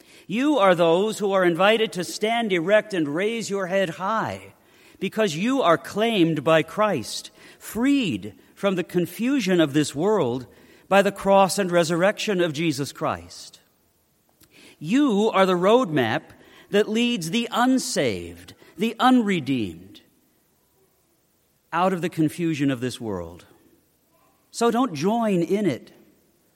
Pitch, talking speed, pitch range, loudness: 195 Hz, 130 wpm, 165-220 Hz, -22 LUFS